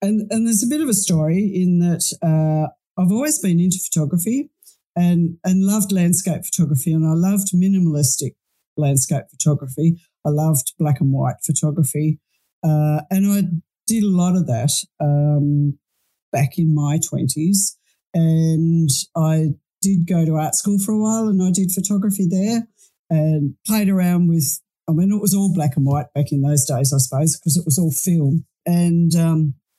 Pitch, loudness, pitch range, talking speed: 165 Hz, -18 LUFS, 150-190 Hz, 175 wpm